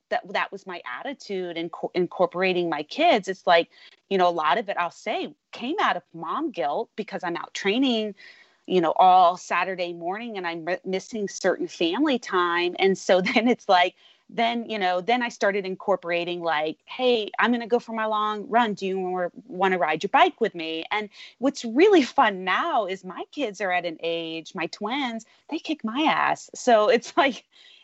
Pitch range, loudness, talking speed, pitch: 180-245 Hz, -24 LUFS, 200 wpm, 200 Hz